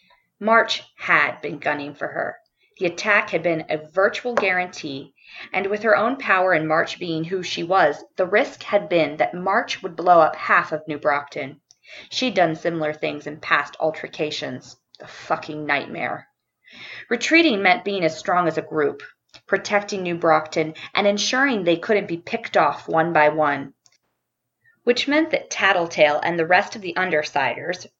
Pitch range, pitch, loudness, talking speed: 155-205 Hz, 175 Hz, -21 LUFS, 165 wpm